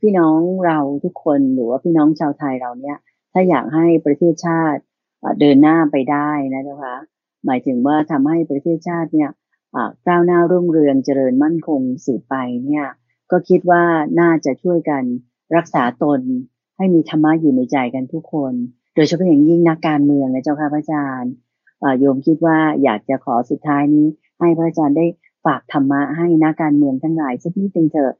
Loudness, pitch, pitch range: -16 LUFS, 150 Hz, 140-165 Hz